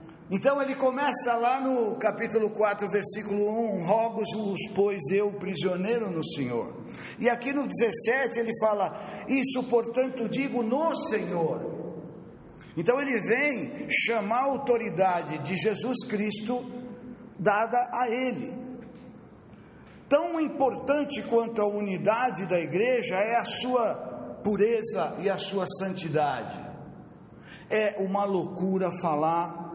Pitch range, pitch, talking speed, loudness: 200-250 Hz, 225 Hz, 115 wpm, -27 LUFS